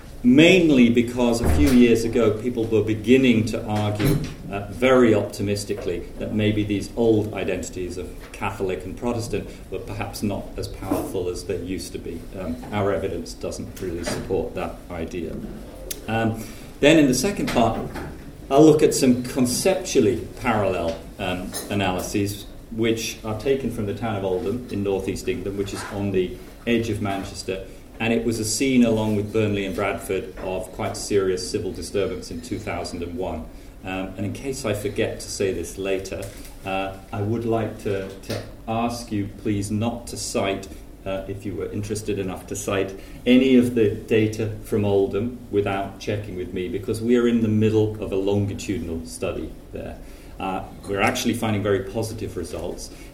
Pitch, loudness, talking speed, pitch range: 105 Hz, -23 LUFS, 165 wpm, 95-115 Hz